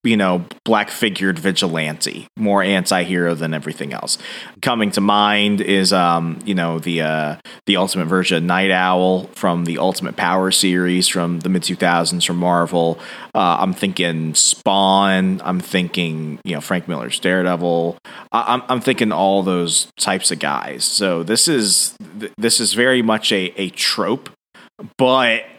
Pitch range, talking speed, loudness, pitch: 85-100 Hz, 160 wpm, -17 LUFS, 90 Hz